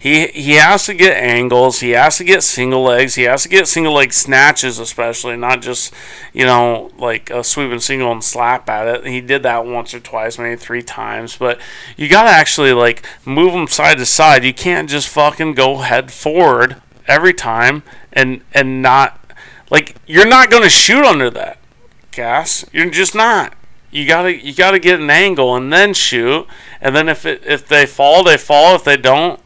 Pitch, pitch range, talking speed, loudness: 130 Hz, 120-155 Hz, 200 wpm, -11 LUFS